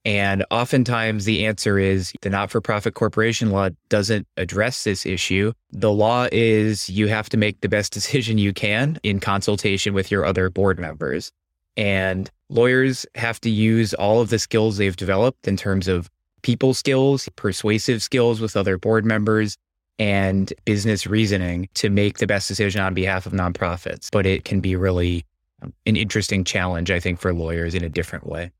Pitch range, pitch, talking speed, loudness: 95-110 Hz, 100 Hz, 175 wpm, -21 LUFS